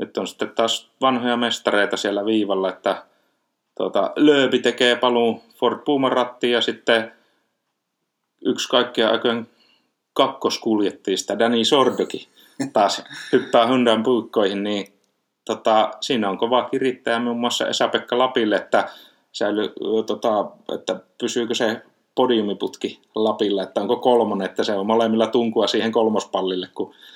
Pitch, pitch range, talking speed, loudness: 115 Hz, 110-120 Hz, 125 wpm, -21 LUFS